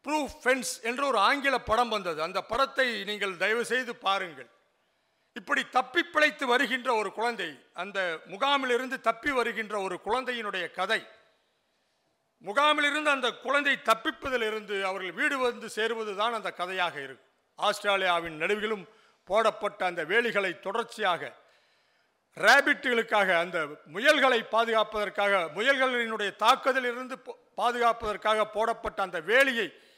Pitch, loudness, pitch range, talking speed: 230 Hz, -27 LUFS, 205-260 Hz, 105 wpm